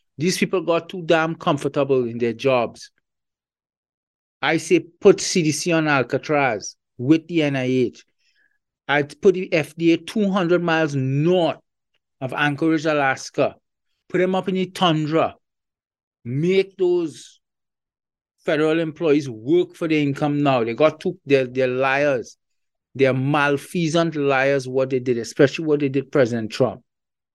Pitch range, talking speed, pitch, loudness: 135-170 Hz, 130 wpm, 155 Hz, -20 LUFS